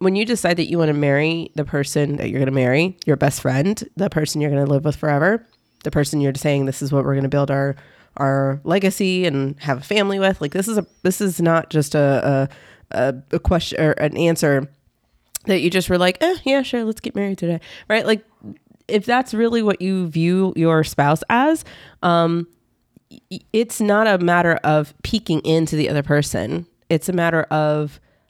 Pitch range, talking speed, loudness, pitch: 145-195 Hz, 210 wpm, -19 LUFS, 165 Hz